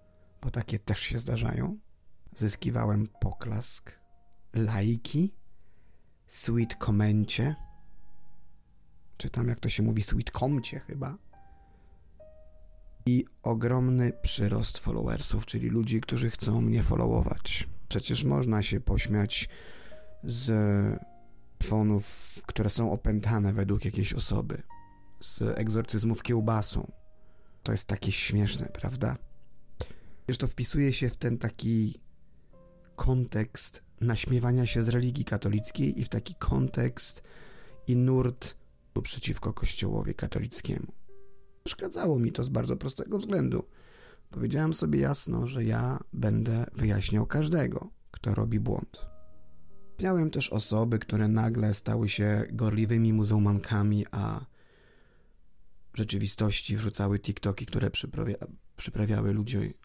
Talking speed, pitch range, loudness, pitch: 105 wpm, 100-120 Hz, -29 LUFS, 110 Hz